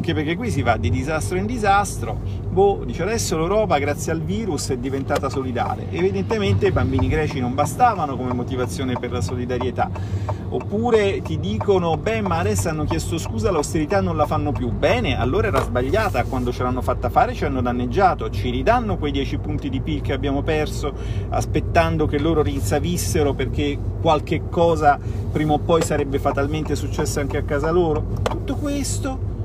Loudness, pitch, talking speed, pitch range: -21 LUFS, 125 Hz, 175 wpm, 100-145 Hz